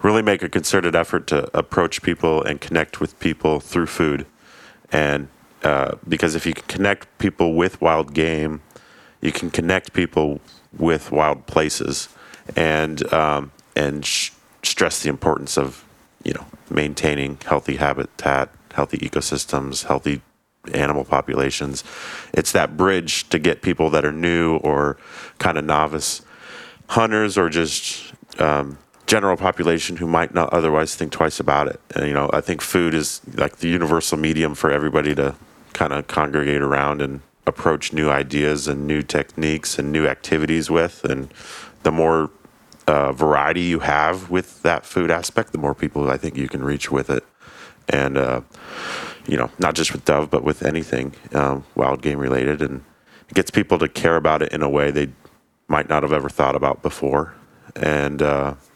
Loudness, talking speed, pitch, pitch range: -20 LUFS, 165 wpm, 75 Hz, 70-80 Hz